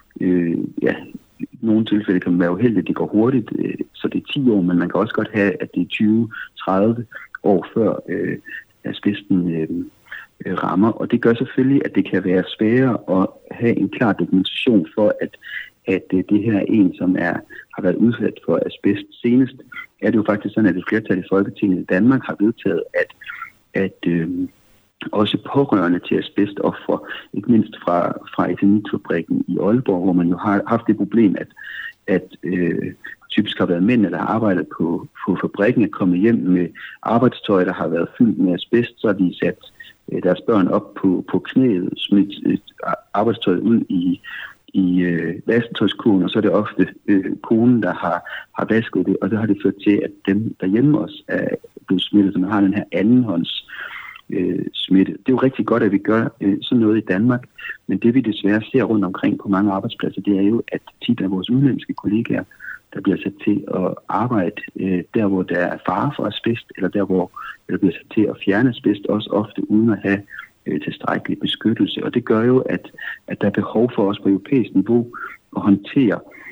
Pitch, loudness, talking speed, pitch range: 105 Hz, -19 LUFS, 200 wpm, 95-115 Hz